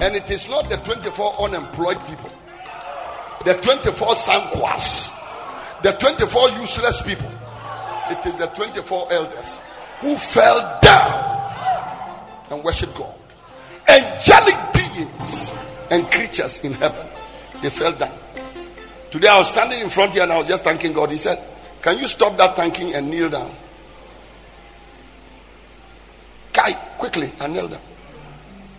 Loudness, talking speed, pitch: -17 LUFS, 130 wpm, 185 Hz